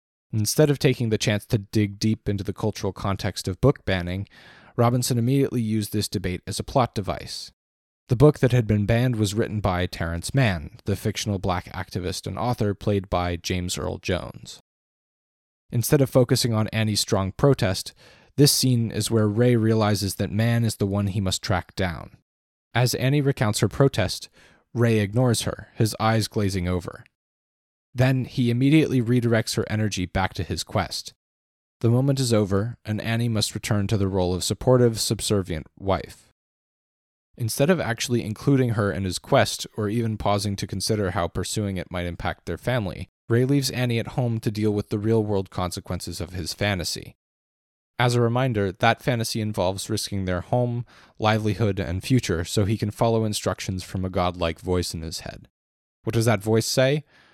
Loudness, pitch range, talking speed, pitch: -24 LUFS, 95-120 Hz, 175 wpm, 105 Hz